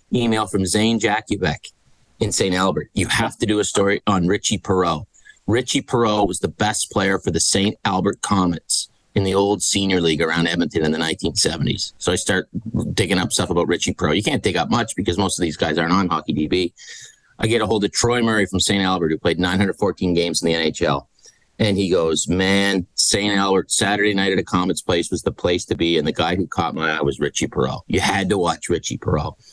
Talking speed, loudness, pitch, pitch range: 220 wpm, -19 LUFS, 95 Hz, 85-105 Hz